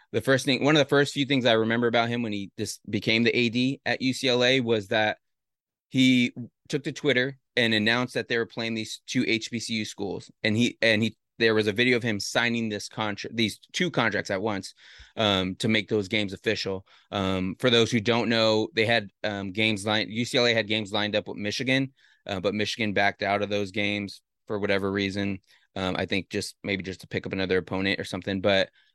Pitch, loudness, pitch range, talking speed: 110 Hz, -25 LUFS, 100-120 Hz, 215 wpm